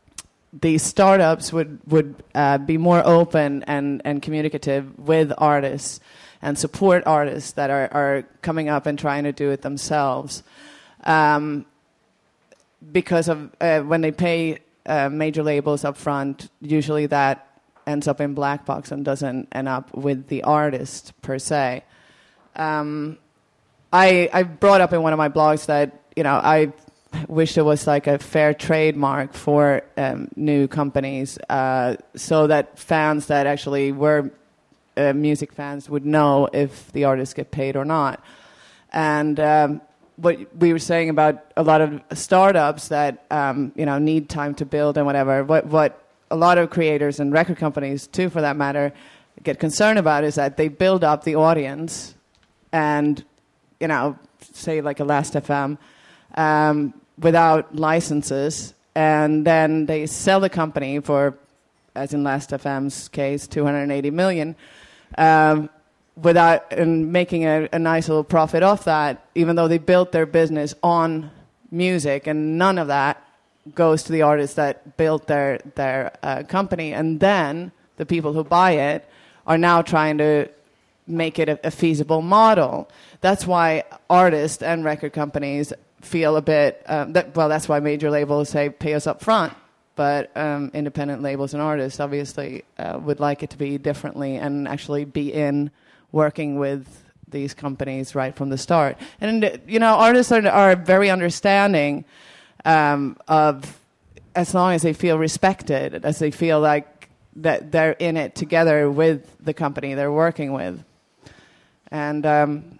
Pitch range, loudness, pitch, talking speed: 145-160 Hz, -20 LUFS, 150 Hz, 160 wpm